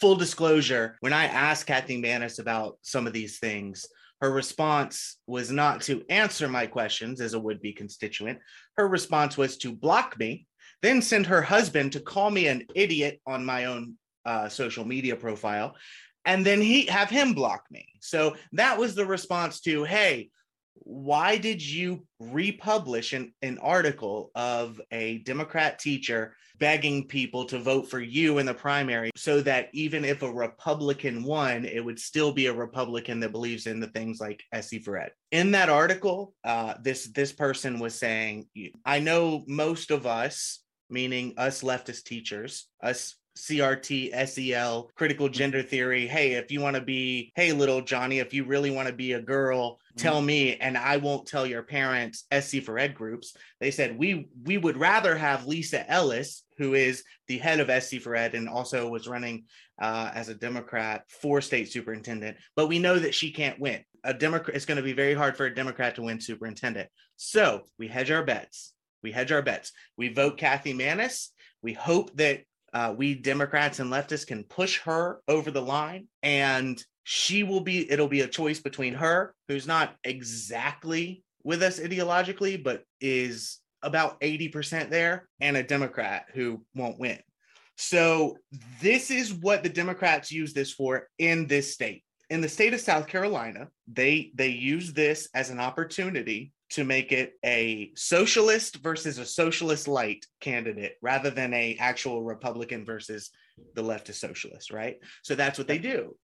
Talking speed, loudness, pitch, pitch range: 175 wpm, -27 LUFS, 135 Hz, 120-155 Hz